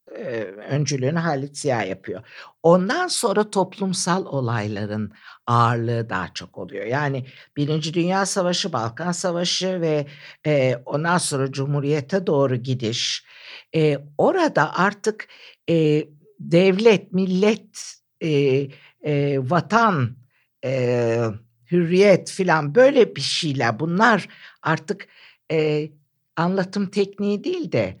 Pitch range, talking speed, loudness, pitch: 135-190 Hz, 85 wpm, -21 LUFS, 155 Hz